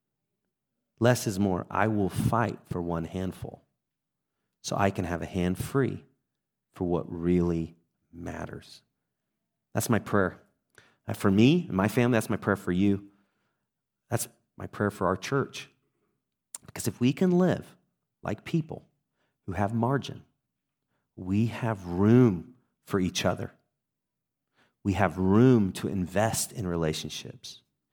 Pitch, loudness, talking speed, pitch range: 100 Hz, -28 LUFS, 135 wpm, 90-125 Hz